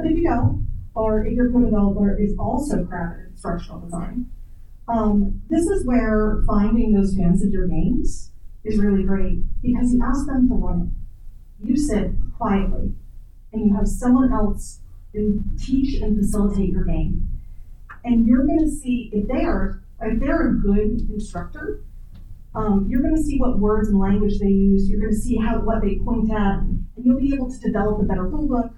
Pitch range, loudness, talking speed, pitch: 200-245 Hz, -21 LUFS, 180 wpm, 215 Hz